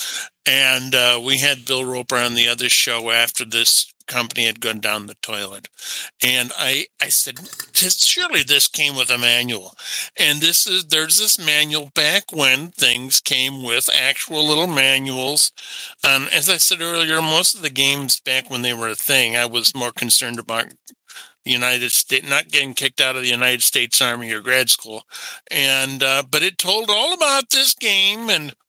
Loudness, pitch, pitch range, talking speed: -16 LUFS, 135 Hz, 125-160 Hz, 185 wpm